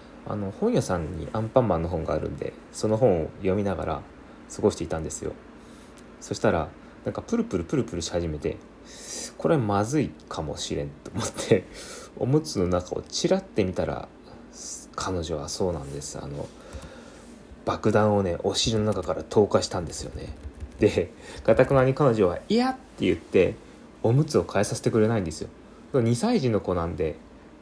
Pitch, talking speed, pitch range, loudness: 100 Hz, 335 characters per minute, 85-125 Hz, -26 LUFS